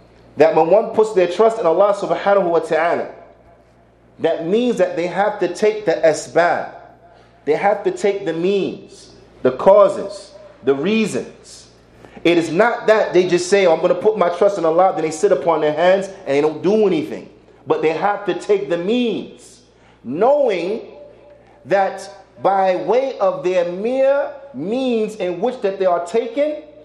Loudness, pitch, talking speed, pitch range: -17 LUFS, 195 Hz, 175 wpm, 170-215 Hz